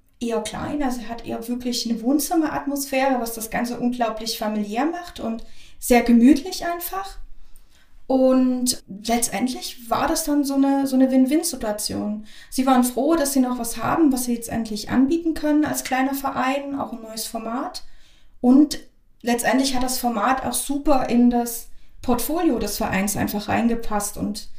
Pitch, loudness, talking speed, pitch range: 250 Hz, -22 LUFS, 155 wpm, 230-280 Hz